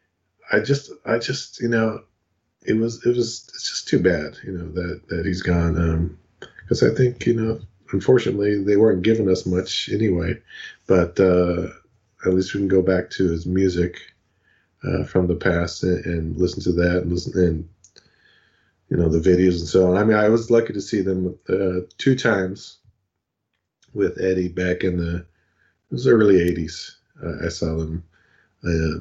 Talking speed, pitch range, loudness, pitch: 180 wpm, 85-100 Hz, -21 LUFS, 90 Hz